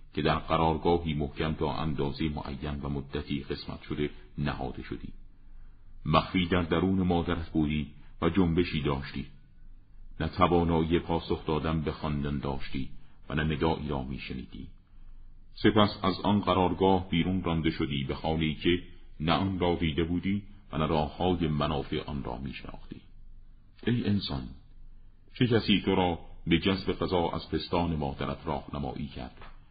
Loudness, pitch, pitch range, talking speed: -30 LUFS, 80 Hz, 75-95 Hz, 140 wpm